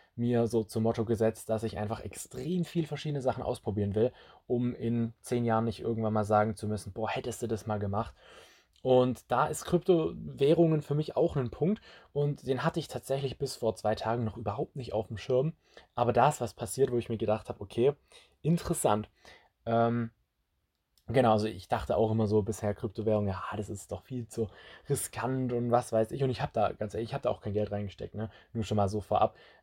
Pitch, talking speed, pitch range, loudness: 115 Hz, 215 wpm, 105-130 Hz, -31 LUFS